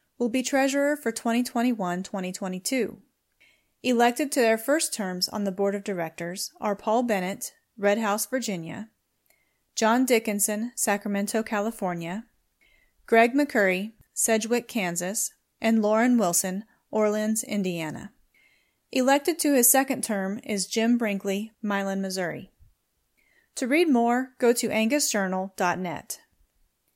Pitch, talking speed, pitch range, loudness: 220 Hz, 115 wpm, 195-240 Hz, -25 LUFS